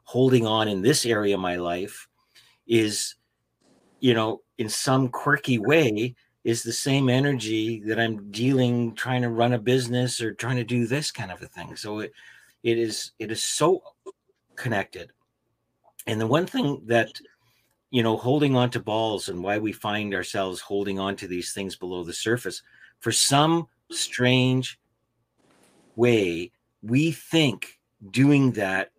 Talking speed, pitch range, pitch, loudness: 155 wpm, 105-130 Hz, 115 Hz, -24 LUFS